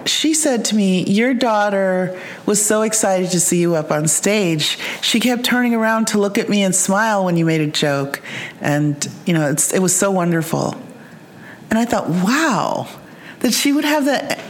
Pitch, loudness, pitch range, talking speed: 200 Hz, -17 LUFS, 170-225 Hz, 195 wpm